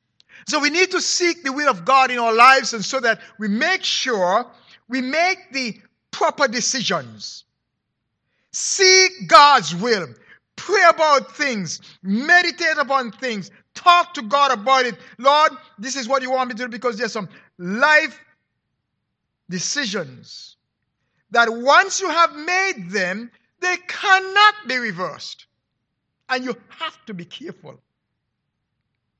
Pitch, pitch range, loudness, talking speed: 265 Hz, 225-315 Hz, -17 LUFS, 140 wpm